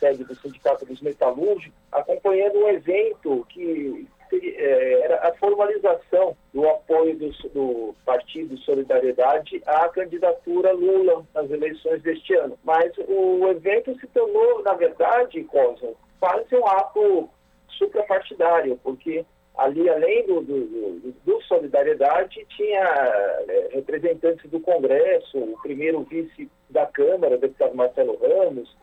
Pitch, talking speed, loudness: 270 Hz, 120 wpm, -22 LUFS